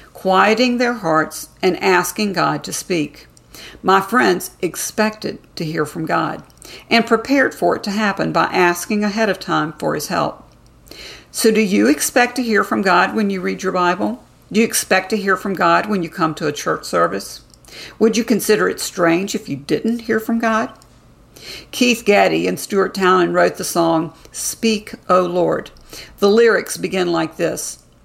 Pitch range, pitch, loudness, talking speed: 175-225 Hz, 195 Hz, -17 LUFS, 180 wpm